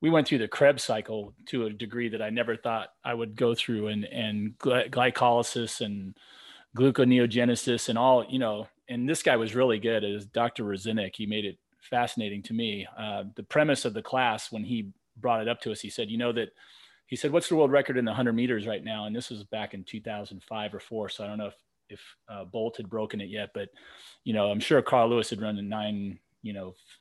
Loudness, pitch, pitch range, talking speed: -28 LUFS, 115 Hz, 105-120 Hz, 235 wpm